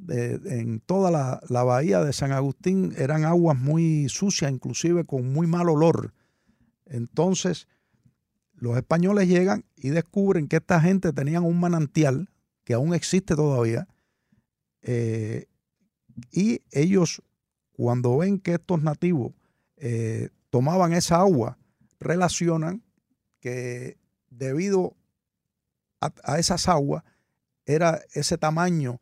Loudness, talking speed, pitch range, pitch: -24 LUFS, 115 wpm, 130-175 Hz, 160 Hz